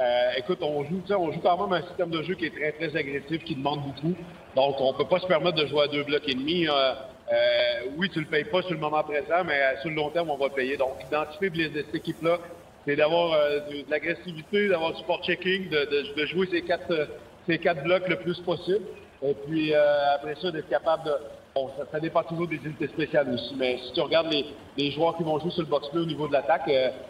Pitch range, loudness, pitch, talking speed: 145-175 Hz, -27 LUFS, 155 Hz, 260 wpm